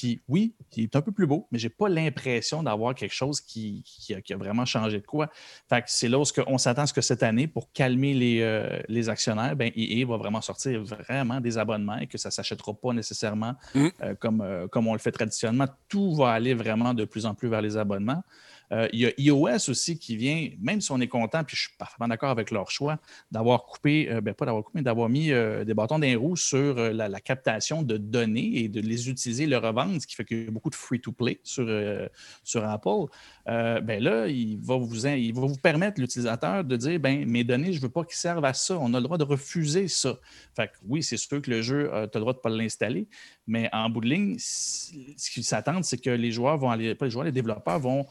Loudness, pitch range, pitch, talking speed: -27 LUFS, 115-140 Hz, 120 Hz, 260 wpm